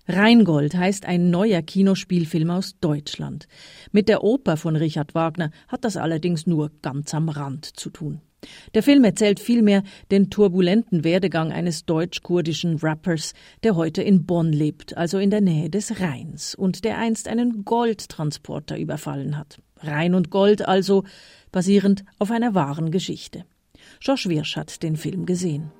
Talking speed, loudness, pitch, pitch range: 150 wpm, -21 LUFS, 180 Hz, 160-200 Hz